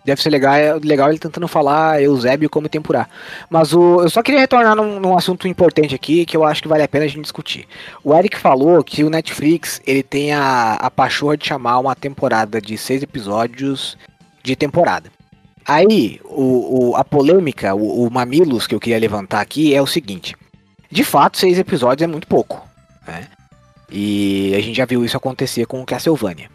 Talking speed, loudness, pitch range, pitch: 190 wpm, -15 LUFS, 125-160 Hz, 140 Hz